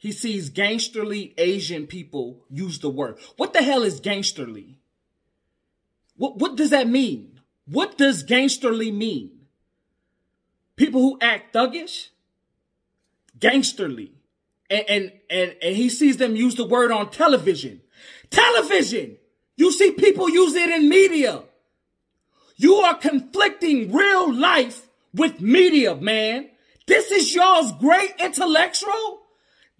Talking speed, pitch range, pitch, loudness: 120 wpm, 205-335 Hz, 255 Hz, -19 LUFS